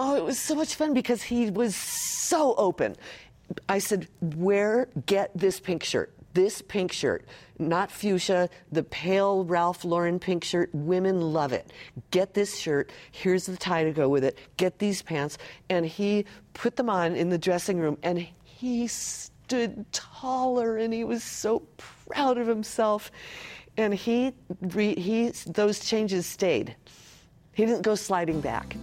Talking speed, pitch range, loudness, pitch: 160 wpm, 175-220 Hz, -27 LUFS, 190 Hz